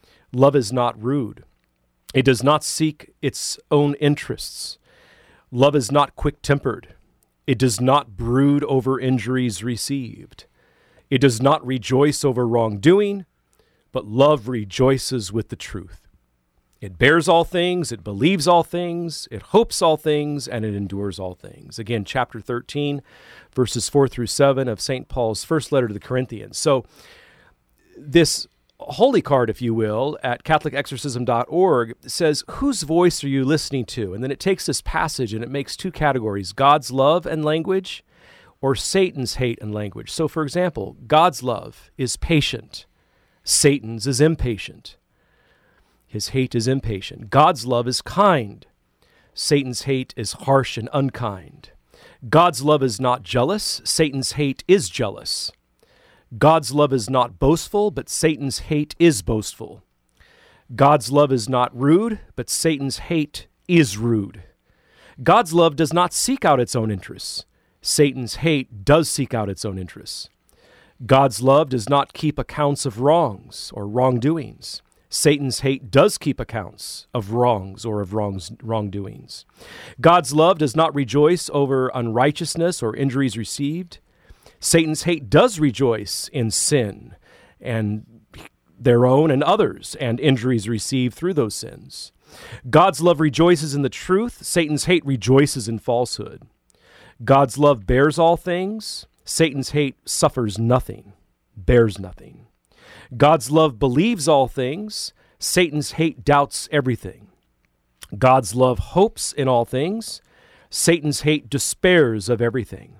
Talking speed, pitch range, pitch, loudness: 140 wpm, 115-150 Hz, 135 Hz, -20 LUFS